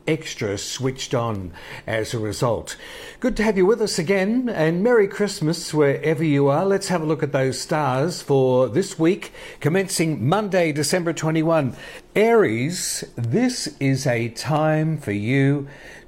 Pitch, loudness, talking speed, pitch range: 155 Hz, -21 LUFS, 150 wpm, 135-185 Hz